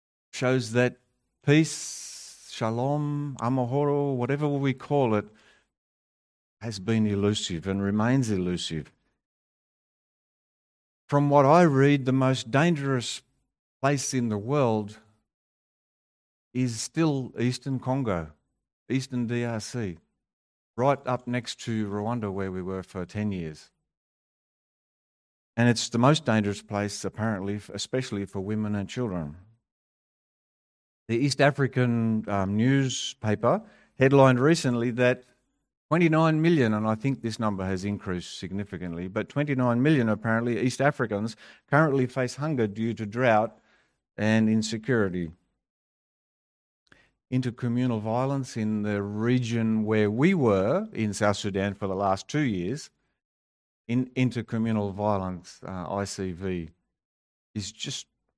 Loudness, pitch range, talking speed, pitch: -26 LUFS, 100-130 Hz, 115 wpm, 115 Hz